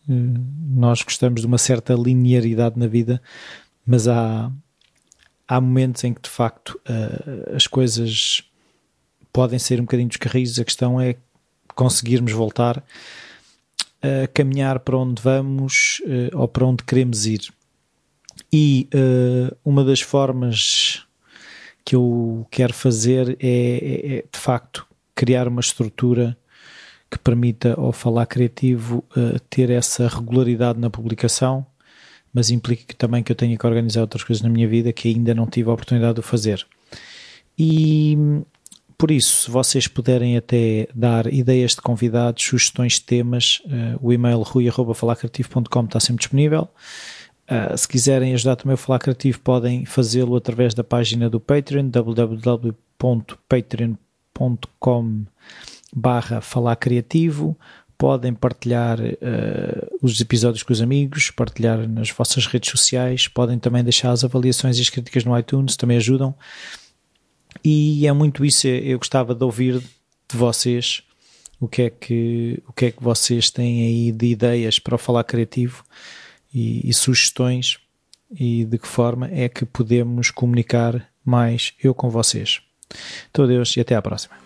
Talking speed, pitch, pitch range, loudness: 145 wpm, 125 Hz, 120-130 Hz, -19 LUFS